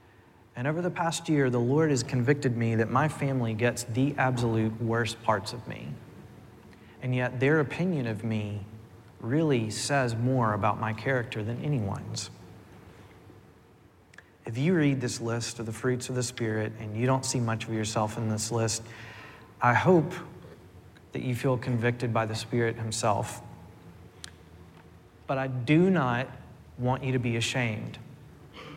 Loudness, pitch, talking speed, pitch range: -28 LUFS, 120 Hz, 155 wpm, 110-130 Hz